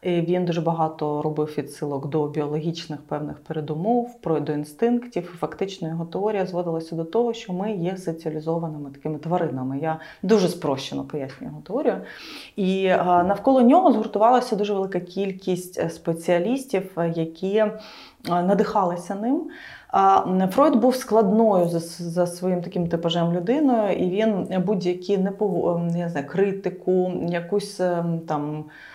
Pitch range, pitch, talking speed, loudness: 165-205 Hz, 180 Hz, 120 wpm, -23 LUFS